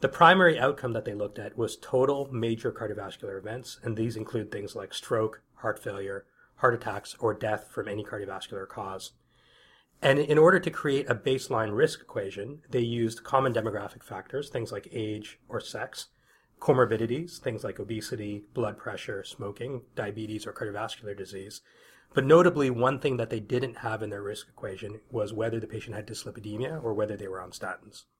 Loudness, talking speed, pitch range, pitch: -29 LUFS, 175 wpm, 105-135 Hz, 115 Hz